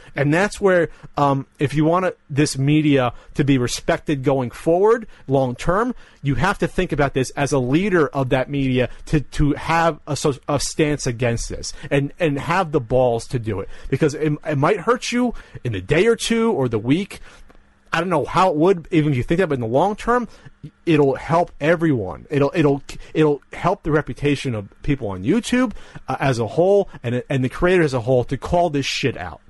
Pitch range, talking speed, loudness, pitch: 135-170 Hz, 210 wpm, -20 LUFS, 145 Hz